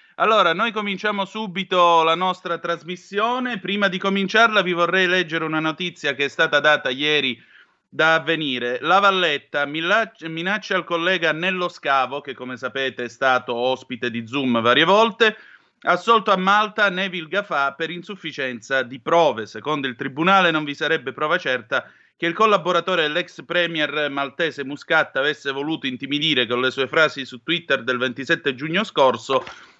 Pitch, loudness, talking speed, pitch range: 160 Hz, -20 LUFS, 155 wpm, 140-190 Hz